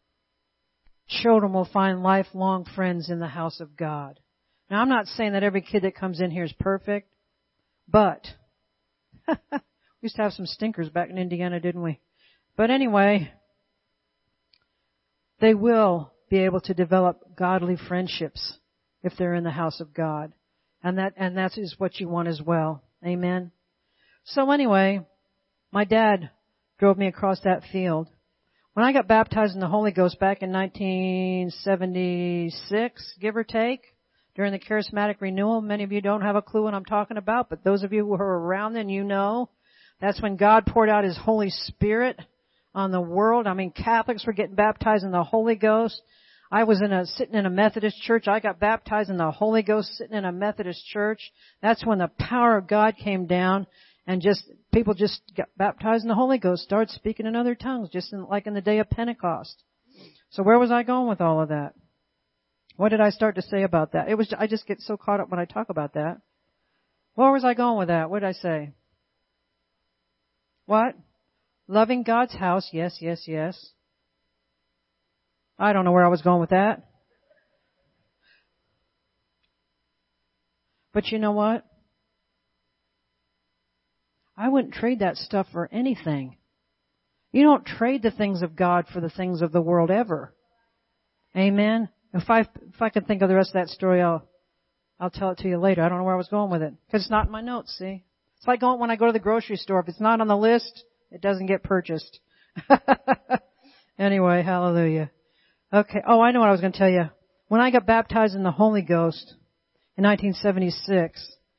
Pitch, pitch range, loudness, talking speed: 195 Hz, 180-220 Hz, -23 LUFS, 185 wpm